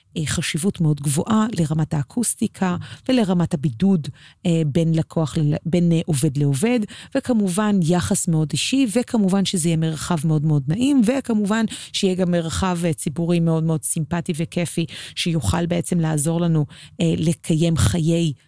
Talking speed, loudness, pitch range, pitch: 125 wpm, -20 LUFS, 160-195 Hz, 170 Hz